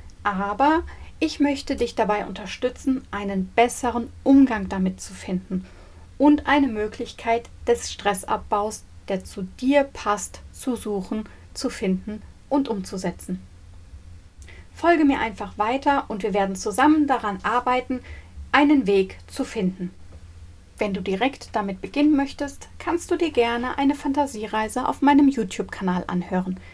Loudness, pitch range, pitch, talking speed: -23 LUFS, 195-275 Hz, 220 Hz, 130 wpm